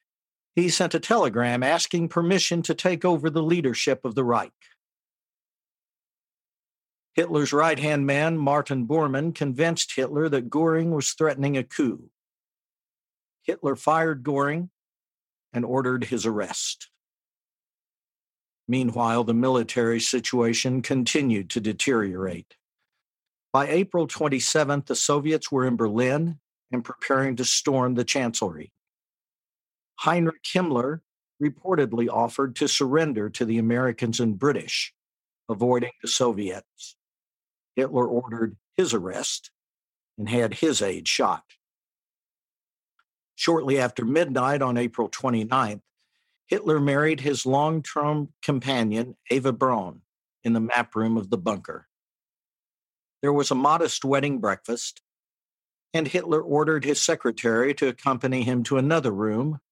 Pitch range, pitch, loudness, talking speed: 120-155 Hz, 135 Hz, -24 LUFS, 115 wpm